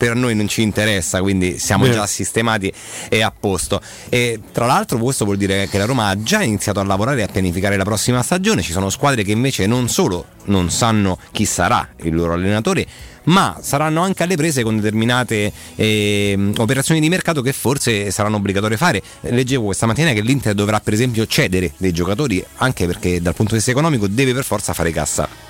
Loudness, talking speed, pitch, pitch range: -17 LUFS, 200 wpm, 105 Hz, 95-125 Hz